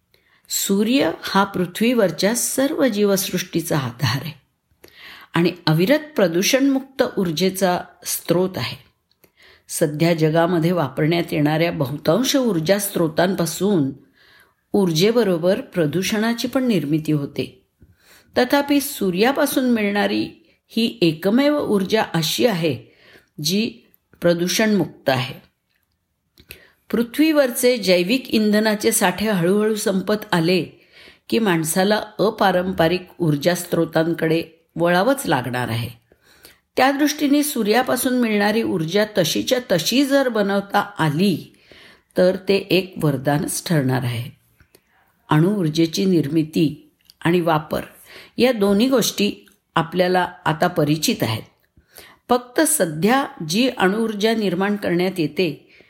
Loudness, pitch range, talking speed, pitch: -19 LUFS, 165-220 Hz, 90 wpm, 185 Hz